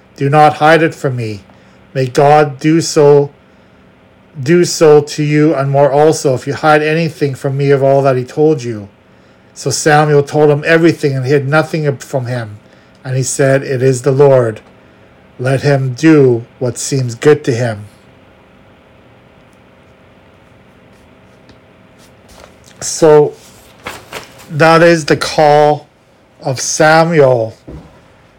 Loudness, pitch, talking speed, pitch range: -11 LUFS, 140 Hz, 130 wpm, 125-150 Hz